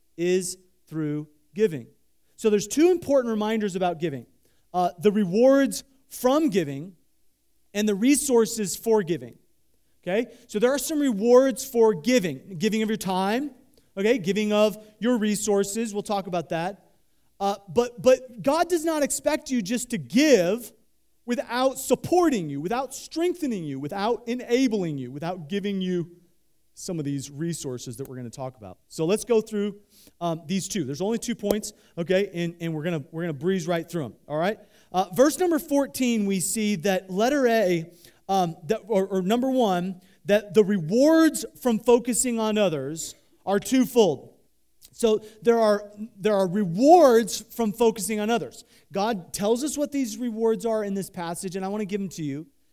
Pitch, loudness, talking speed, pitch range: 210 Hz, -24 LUFS, 175 wpm, 180-240 Hz